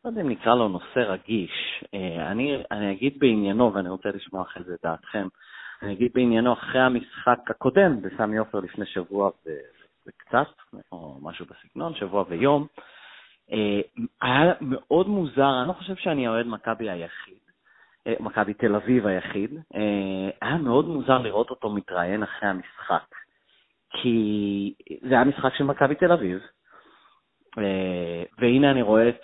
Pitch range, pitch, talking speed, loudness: 100-130 Hz, 110 Hz, 140 wpm, -24 LUFS